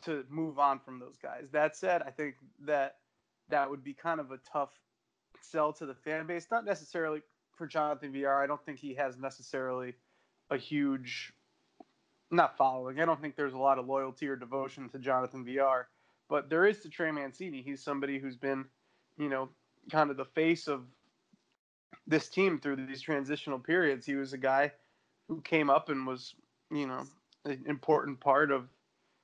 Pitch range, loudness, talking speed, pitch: 135-155 Hz, -33 LUFS, 185 wpm, 140 Hz